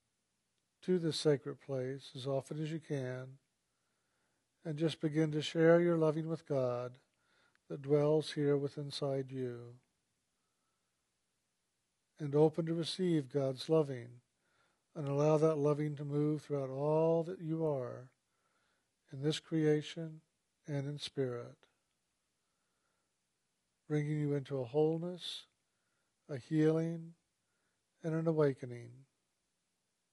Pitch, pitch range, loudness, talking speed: 150 Hz, 135-160 Hz, -35 LUFS, 115 wpm